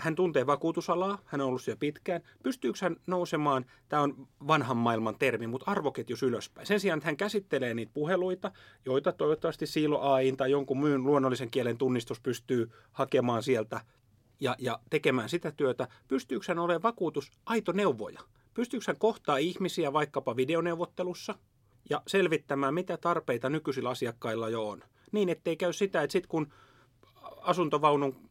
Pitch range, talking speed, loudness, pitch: 130-175 Hz, 155 wpm, -31 LUFS, 150 Hz